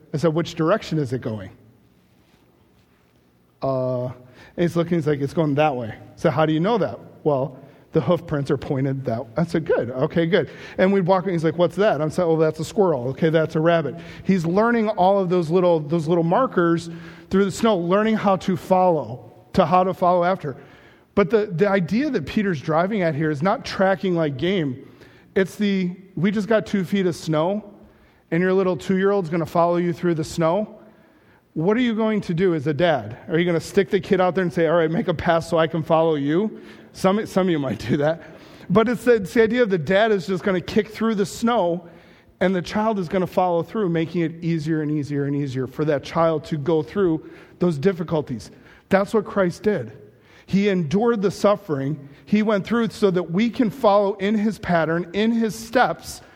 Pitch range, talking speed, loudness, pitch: 155-195 Hz, 225 wpm, -21 LUFS, 175 Hz